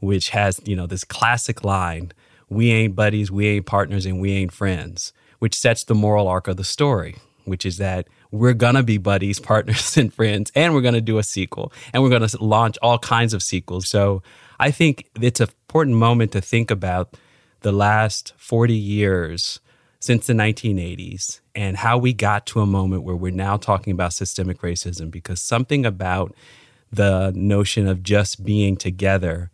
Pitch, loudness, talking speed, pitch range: 105 Hz, -20 LUFS, 185 wpm, 95-115 Hz